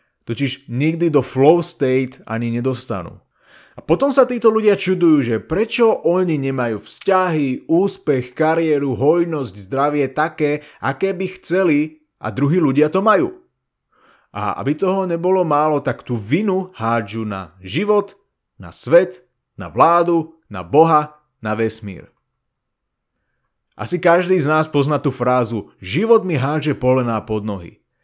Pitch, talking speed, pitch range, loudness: 150 Hz, 135 wpm, 125-175 Hz, -18 LUFS